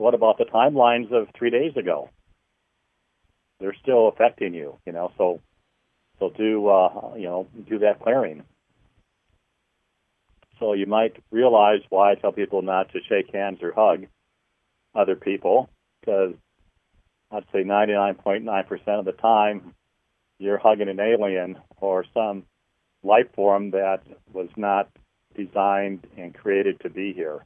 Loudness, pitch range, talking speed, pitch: -22 LUFS, 95-110 Hz, 140 wpm, 100 Hz